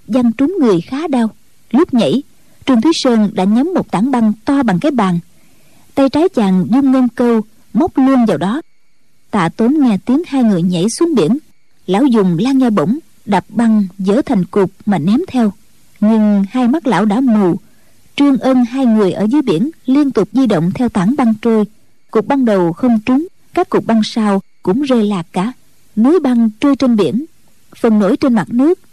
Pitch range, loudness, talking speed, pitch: 205-265 Hz, -13 LUFS, 195 wpm, 235 Hz